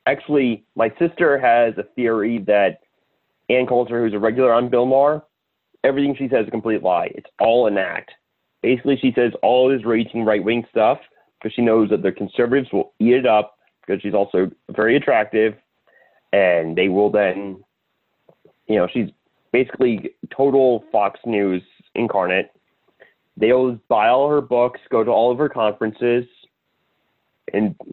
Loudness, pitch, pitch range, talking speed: -19 LUFS, 115 Hz, 105-130 Hz, 160 wpm